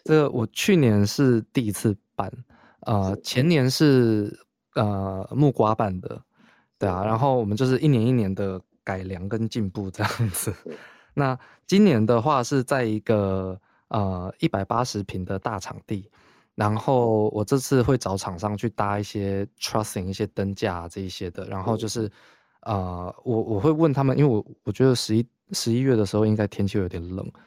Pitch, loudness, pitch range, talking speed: 110 Hz, -24 LUFS, 100-125 Hz, 265 characters per minute